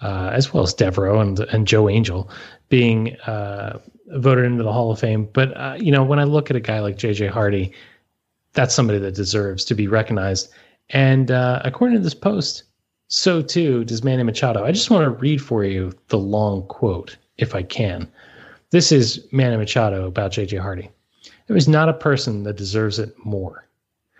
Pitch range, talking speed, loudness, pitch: 105-135 Hz, 190 wpm, -19 LUFS, 110 Hz